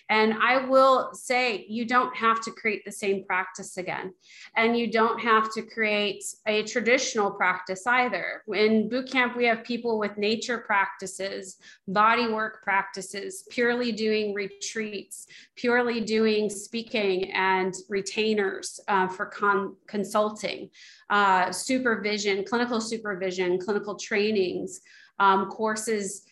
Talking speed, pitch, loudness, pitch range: 125 wpm, 210 Hz, -26 LUFS, 195-225 Hz